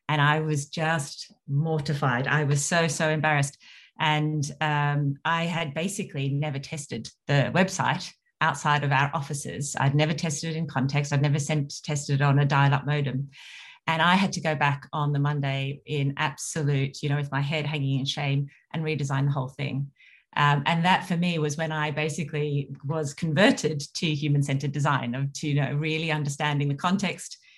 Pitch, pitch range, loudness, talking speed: 150 Hz, 140-160 Hz, -26 LUFS, 185 wpm